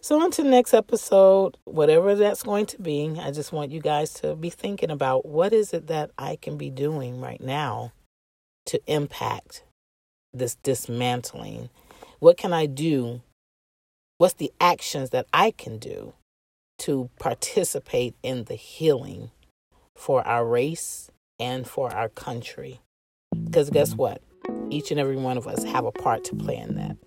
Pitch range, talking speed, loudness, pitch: 120-170 Hz, 160 wpm, -24 LUFS, 140 Hz